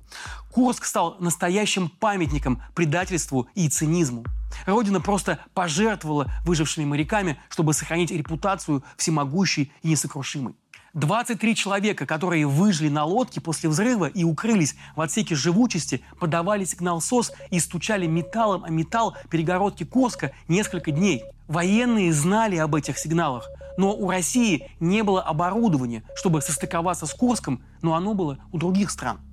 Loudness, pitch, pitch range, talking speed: -24 LUFS, 170 Hz, 155-195 Hz, 130 wpm